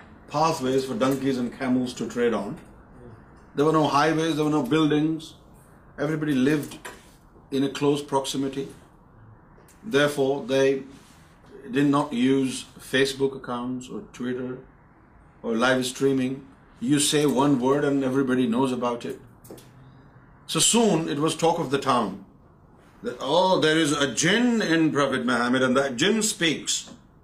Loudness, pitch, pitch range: -23 LUFS, 135 Hz, 130-150 Hz